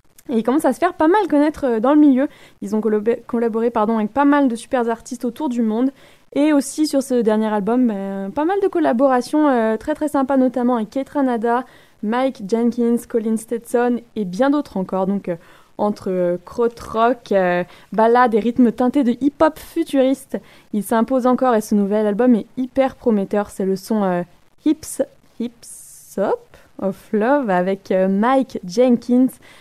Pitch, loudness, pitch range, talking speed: 240 Hz, -19 LUFS, 215-270 Hz, 180 wpm